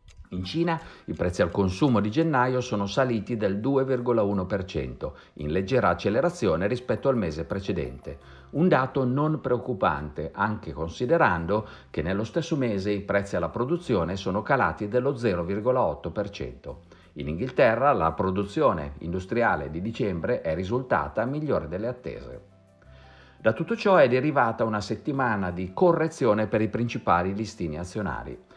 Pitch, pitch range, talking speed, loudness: 105 Hz, 90-125 Hz, 130 wpm, -26 LUFS